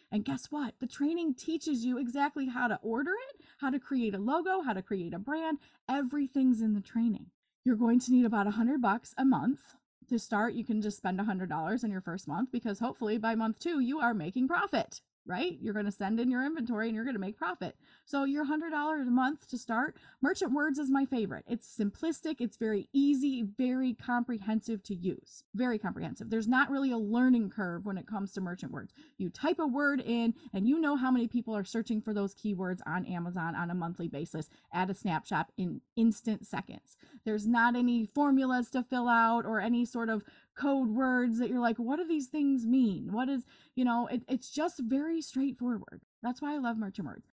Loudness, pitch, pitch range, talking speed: -32 LUFS, 240 Hz, 215-275 Hz, 215 wpm